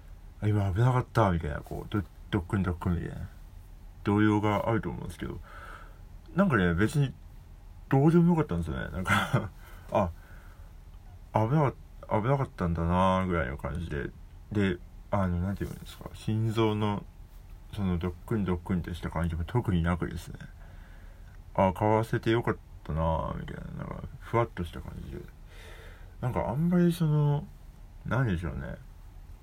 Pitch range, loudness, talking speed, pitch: 85-110 Hz, -29 LUFS, 320 characters per minute, 90 Hz